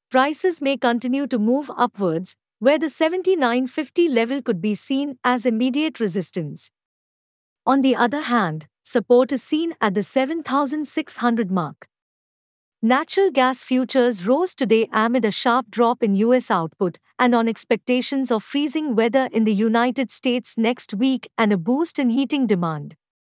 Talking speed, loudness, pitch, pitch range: 145 wpm, -20 LUFS, 245 Hz, 220-270 Hz